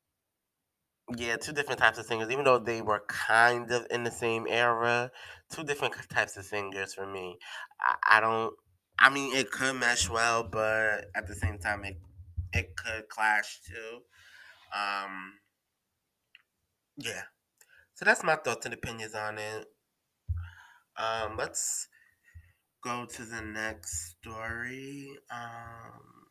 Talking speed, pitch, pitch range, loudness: 135 wpm, 110 Hz, 100-120 Hz, -30 LUFS